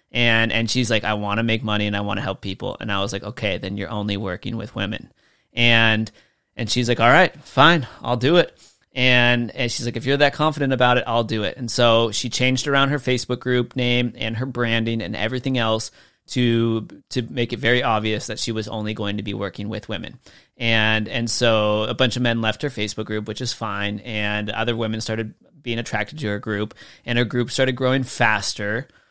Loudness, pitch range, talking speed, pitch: -21 LUFS, 110-125 Hz, 225 wpm, 115 Hz